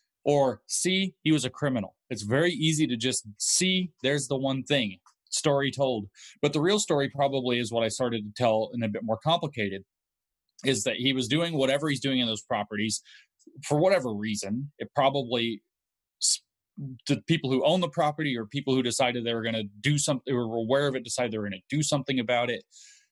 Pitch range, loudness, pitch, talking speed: 115-145 Hz, -27 LUFS, 135 Hz, 210 wpm